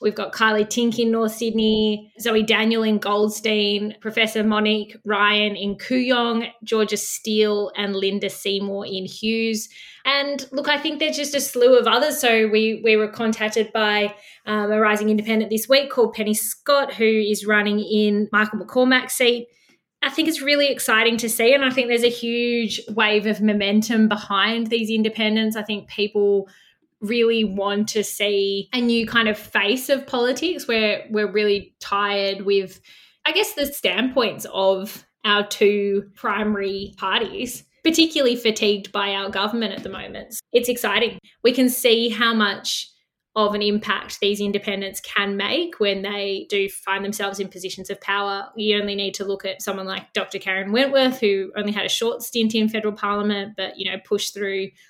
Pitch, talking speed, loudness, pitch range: 215 Hz, 175 wpm, -20 LUFS, 205-235 Hz